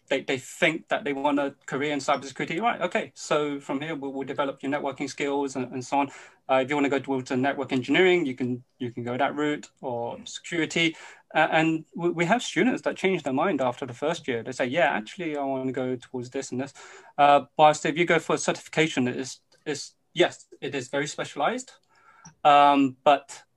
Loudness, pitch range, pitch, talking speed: -26 LUFS, 135-160 Hz, 140 Hz, 225 wpm